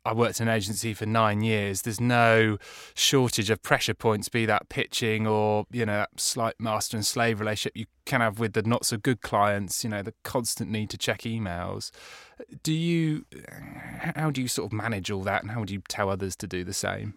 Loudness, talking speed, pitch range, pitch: -27 LUFS, 220 wpm, 105-120 Hz, 110 Hz